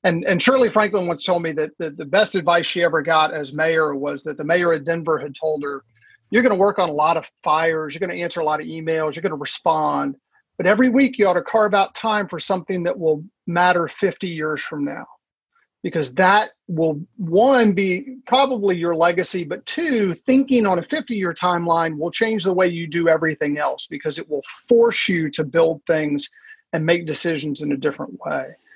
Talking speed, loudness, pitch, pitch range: 215 wpm, -20 LUFS, 175 Hz, 160-205 Hz